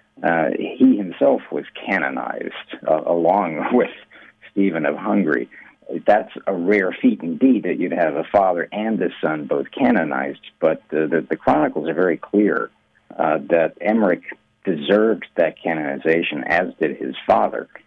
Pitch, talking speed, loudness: 110 Hz, 150 wpm, -20 LUFS